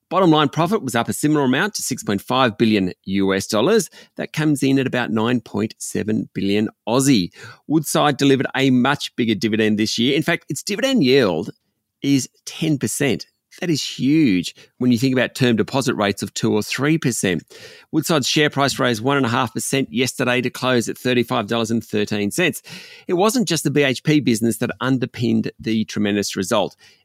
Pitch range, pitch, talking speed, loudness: 115-145 Hz, 125 Hz, 160 wpm, -19 LUFS